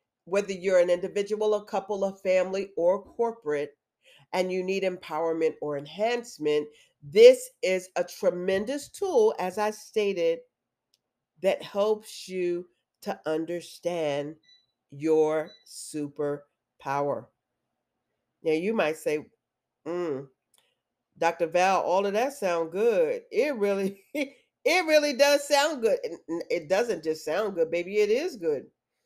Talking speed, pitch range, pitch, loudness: 120 wpm, 160-215 Hz, 185 Hz, -27 LUFS